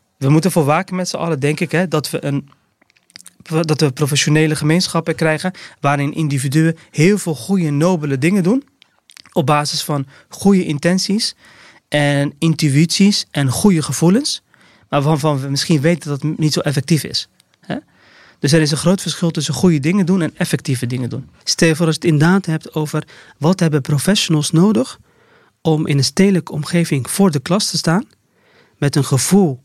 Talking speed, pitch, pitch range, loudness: 175 wpm, 160 Hz, 150-180 Hz, -16 LUFS